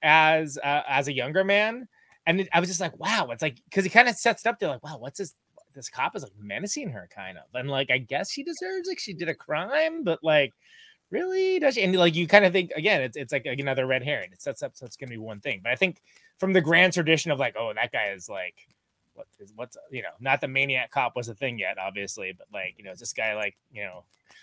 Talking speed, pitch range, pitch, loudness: 280 wpm, 135-205 Hz, 165 Hz, -25 LUFS